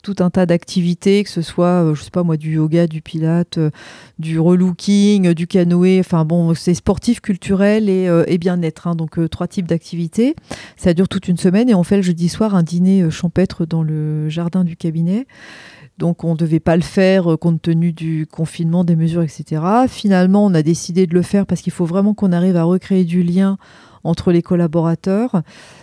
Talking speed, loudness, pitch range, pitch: 200 wpm, -16 LUFS, 165-190 Hz, 175 Hz